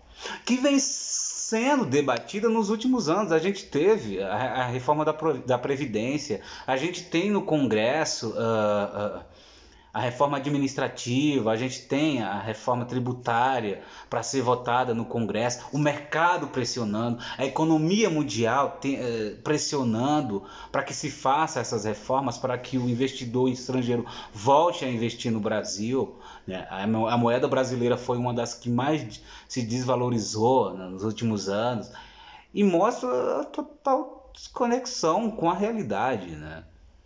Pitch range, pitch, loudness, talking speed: 115-155 Hz, 130 Hz, -26 LUFS, 140 wpm